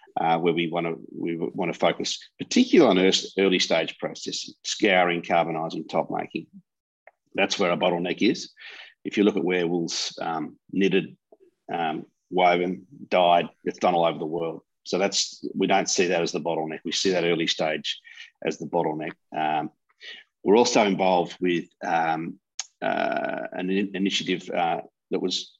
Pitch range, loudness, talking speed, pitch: 85-95 Hz, -25 LUFS, 165 wpm, 90 Hz